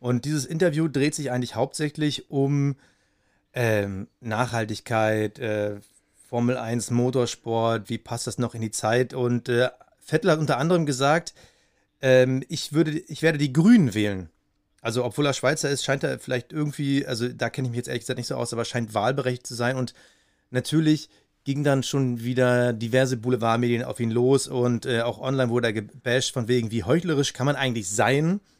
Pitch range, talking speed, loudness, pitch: 115-140 Hz, 185 wpm, -24 LUFS, 125 Hz